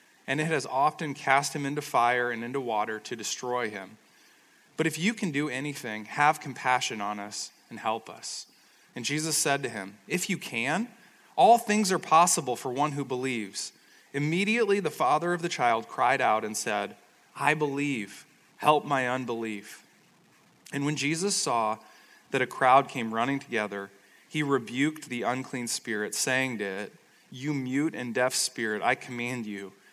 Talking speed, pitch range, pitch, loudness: 170 wpm, 120-150 Hz, 135 Hz, -28 LUFS